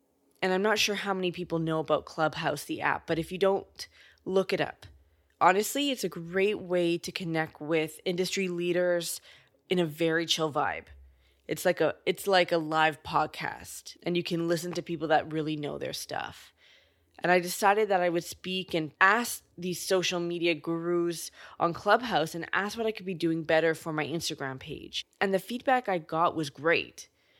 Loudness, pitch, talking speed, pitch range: -29 LUFS, 175 Hz, 190 wpm, 160-190 Hz